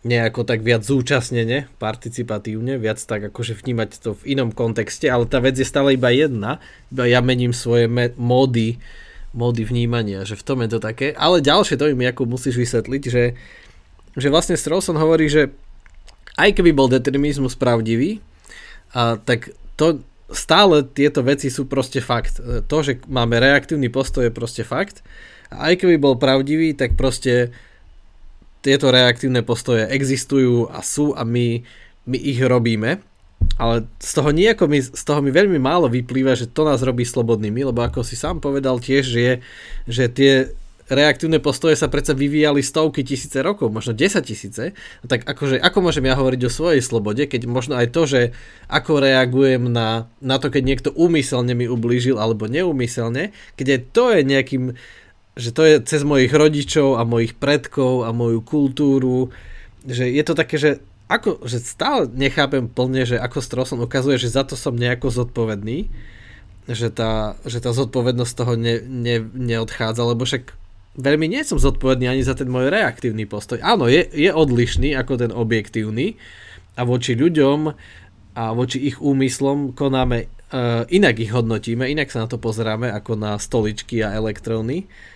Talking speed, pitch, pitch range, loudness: 165 wpm, 125 Hz, 115-140 Hz, -19 LUFS